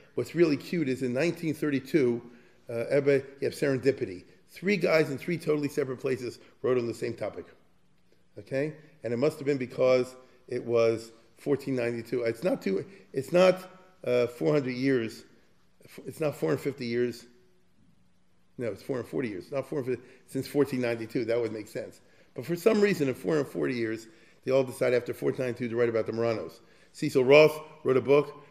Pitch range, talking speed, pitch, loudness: 120-150 Hz, 165 wpm, 130 Hz, -28 LUFS